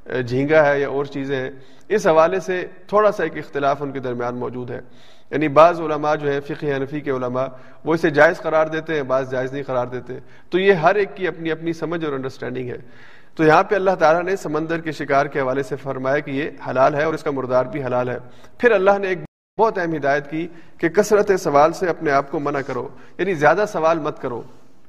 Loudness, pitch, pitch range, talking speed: -20 LUFS, 150 Hz, 135-165 Hz, 230 wpm